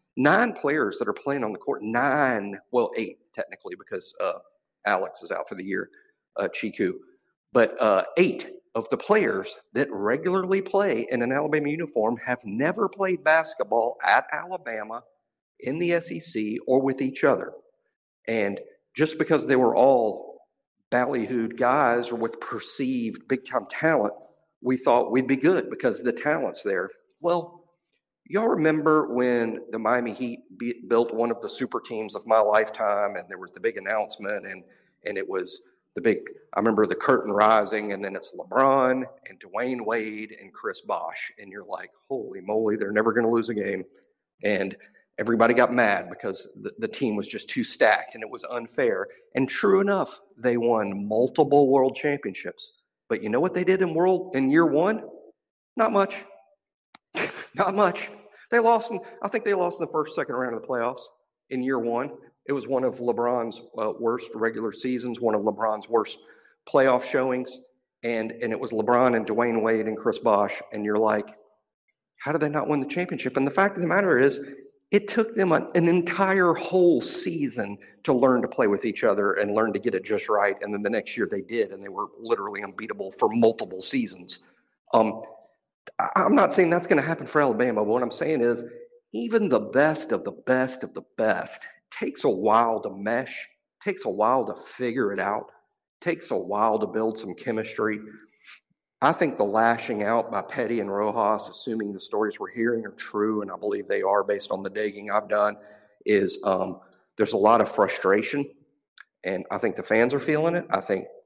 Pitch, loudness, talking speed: 135 Hz, -25 LUFS, 190 wpm